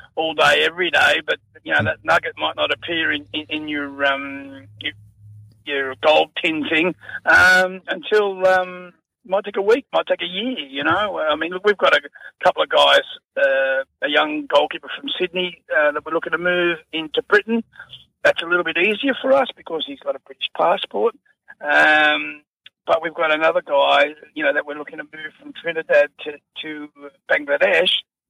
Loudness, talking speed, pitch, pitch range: -19 LUFS, 195 wpm, 170 Hz, 150-230 Hz